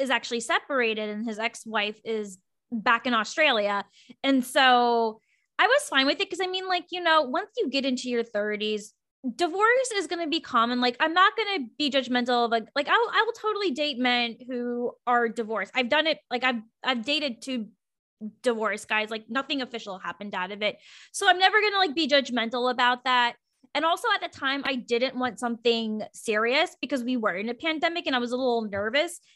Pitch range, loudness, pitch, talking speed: 230-310 Hz, -25 LUFS, 250 Hz, 210 wpm